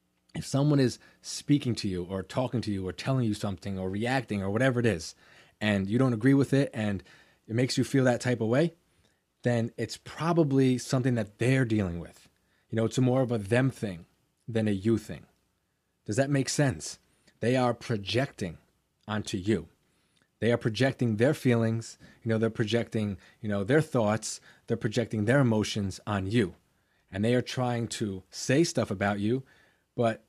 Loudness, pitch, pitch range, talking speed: -29 LUFS, 115 Hz, 105-130 Hz, 185 wpm